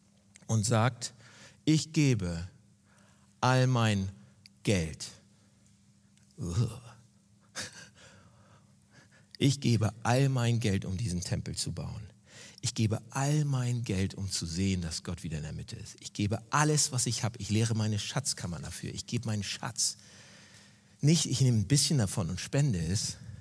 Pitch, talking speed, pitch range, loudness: 115 Hz, 145 wpm, 100-130 Hz, -30 LUFS